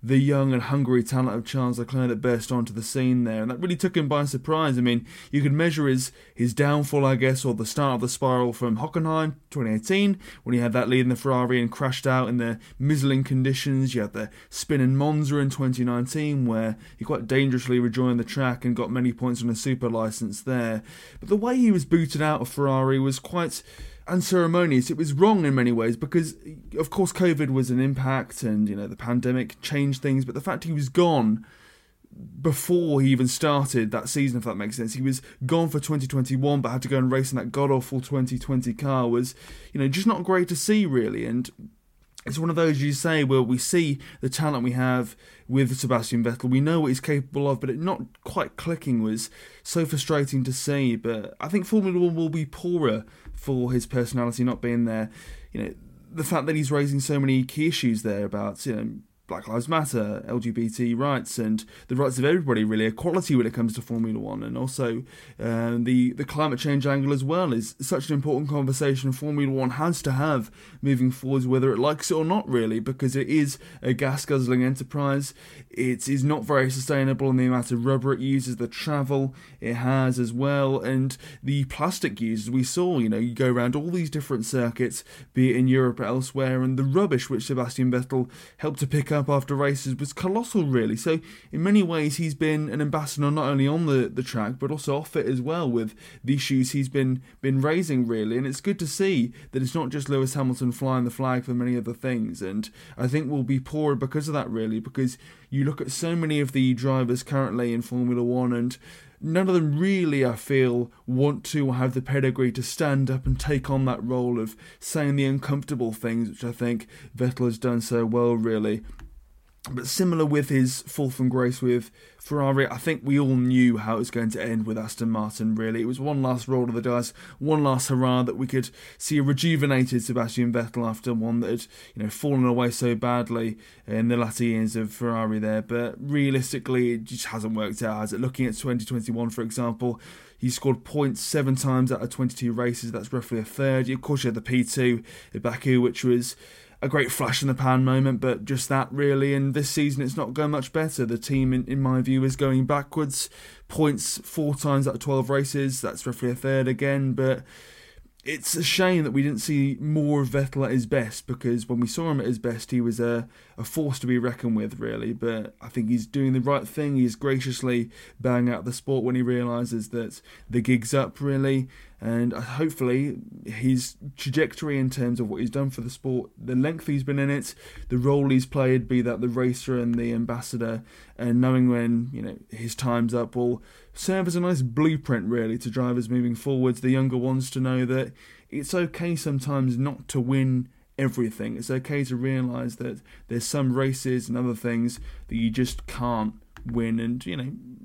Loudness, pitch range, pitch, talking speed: -25 LUFS, 120-140 Hz, 130 Hz, 210 wpm